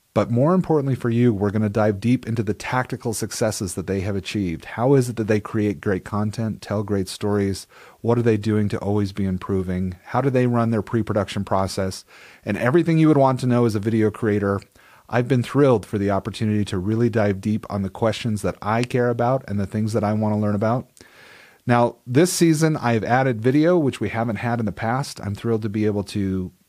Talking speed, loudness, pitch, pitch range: 225 wpm, -21 LUFS, 110 Hz, 100-120 Hz